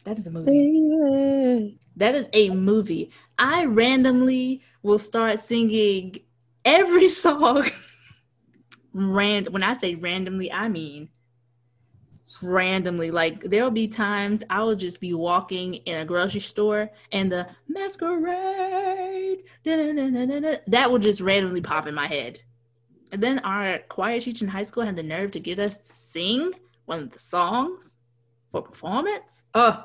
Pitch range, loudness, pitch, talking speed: 175-255 Hz, -23 LUFS, 205 Hz, 140 wpm